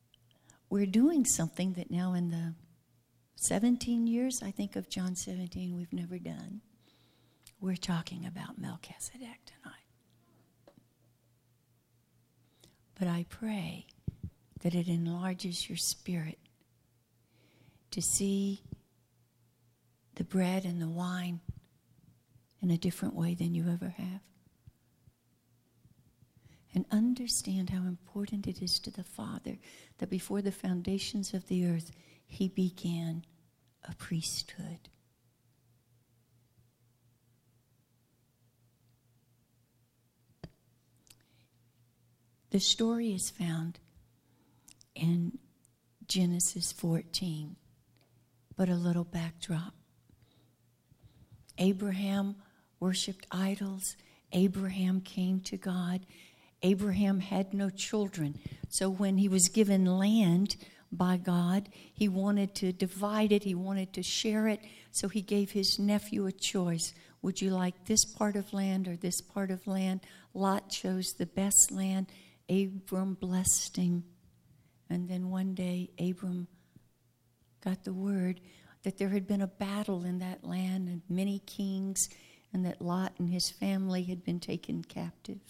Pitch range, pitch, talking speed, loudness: 155-195 Hz, 180 Hz, 115 wpm, -33 LUFS